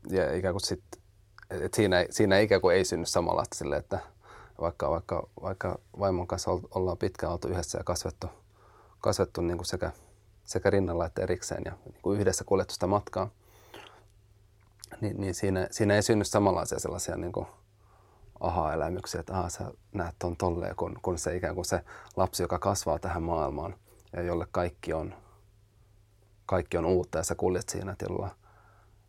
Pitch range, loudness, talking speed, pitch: 90-105 Hz, -30 LUFS, 160 wpm, 95 Hz